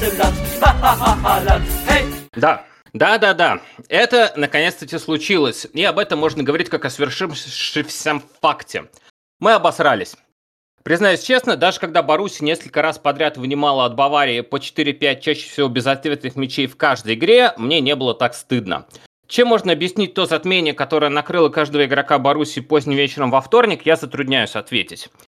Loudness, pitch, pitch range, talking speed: -17 LUFS, 145 Hz, 135-160 Hz, 140 wpm